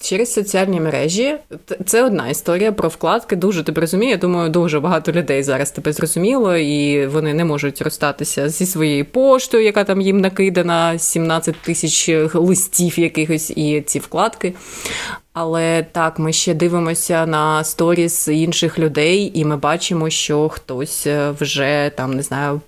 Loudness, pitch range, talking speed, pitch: -17 LUFS, 150-180 Hz, 150 wpm, 165 Hz